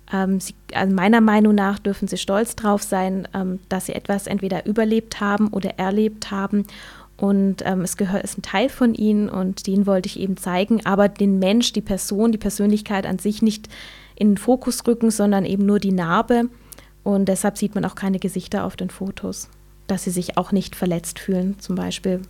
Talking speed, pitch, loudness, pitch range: 195 wpm, 200 Hz, -21 LUFS, 190-210 Hz